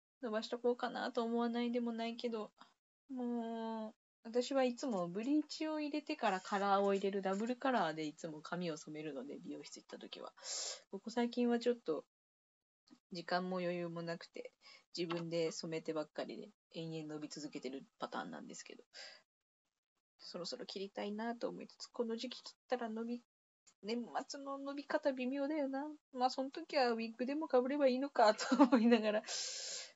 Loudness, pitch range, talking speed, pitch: -39 LUFS, 185-265 Hz, 355 characters per minute, 235 Hz